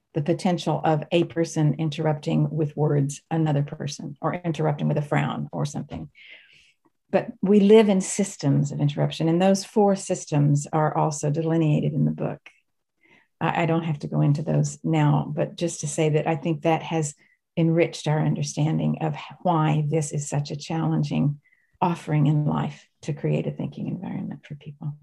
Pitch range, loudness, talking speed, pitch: 145-165 Hz, -24 LUFS, 170 wpm, 155 Hz